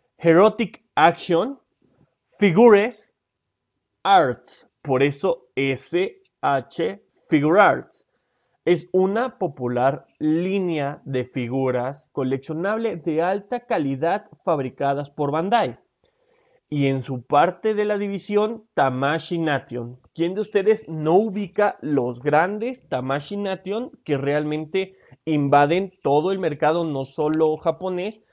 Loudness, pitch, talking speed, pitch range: -22 LUFS, 165 Hz, 105 wpm, 140-205 Hz